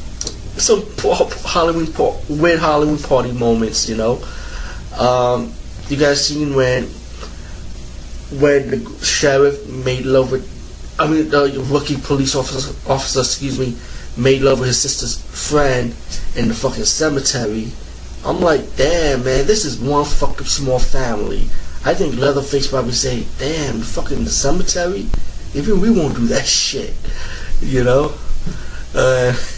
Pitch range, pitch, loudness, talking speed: 115-145 Hz, 130 Hz, -17 LUFS, 140 wpm